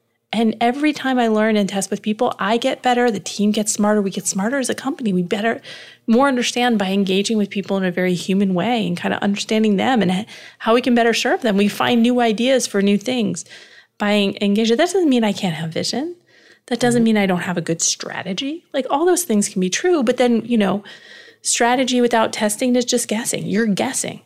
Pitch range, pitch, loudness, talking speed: 200-245 Hz, 220 Hz, -18 LUFS, 225 wpm